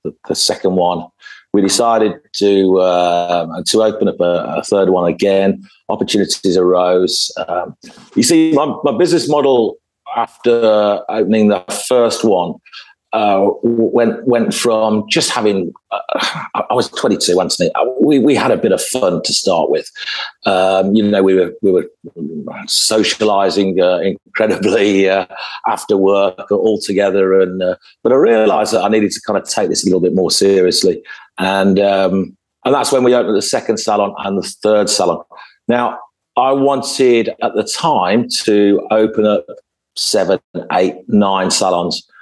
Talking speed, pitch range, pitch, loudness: 155 wpm, 95-120 Hz, 105 Hz, -14 LUFS